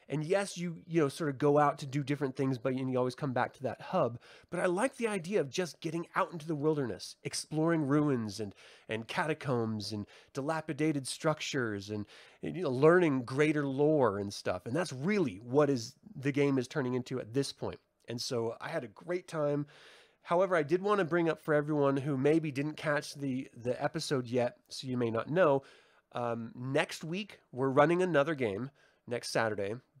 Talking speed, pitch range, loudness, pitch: 200 wpm, 125-160 Hz, -33 LUFS, 145 Hz